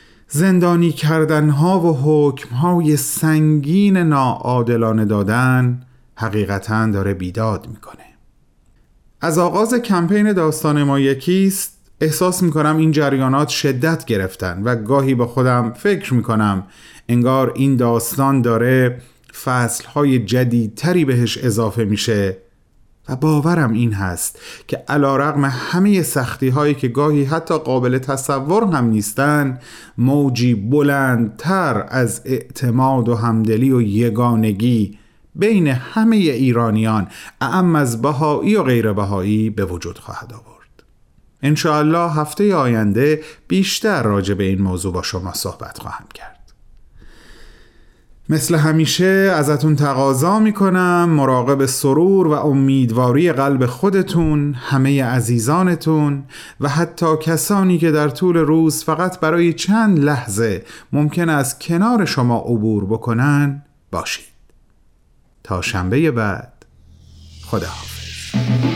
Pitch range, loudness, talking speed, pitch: 115-160 Hz, -16 LUFS, 110 wpm, 135 Hz